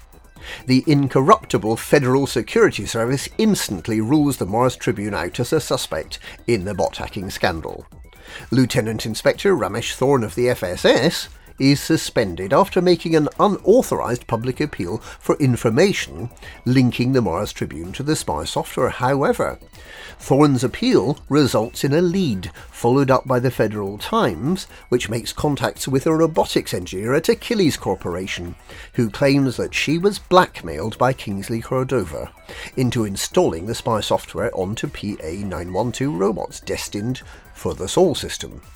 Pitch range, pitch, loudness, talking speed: 110-140 Hz, 125 Hz, -20 LUFS, 140 wpm